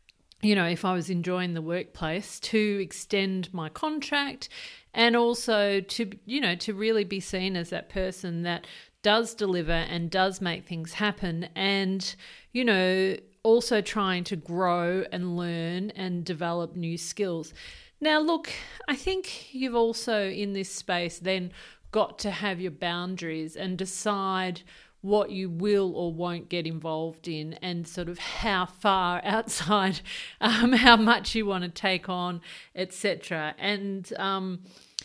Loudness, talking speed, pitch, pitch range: -28 LUFS, 150 wpm, 190 Hz, 175-210 Hz